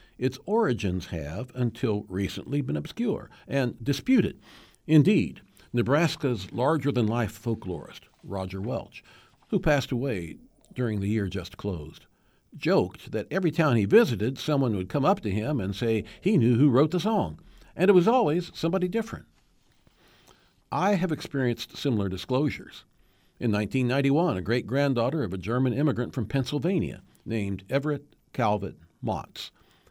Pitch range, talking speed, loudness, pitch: 105-145 Hz, 135 wpm, -27 LUFS, 125 Hz